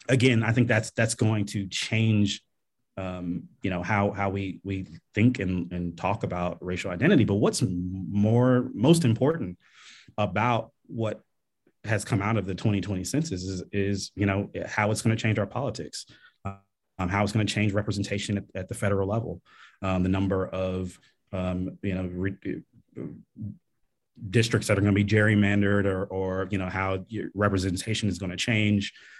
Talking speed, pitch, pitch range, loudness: 175 wpm, 100 Hz, 95-110 Hz, -27 LUFS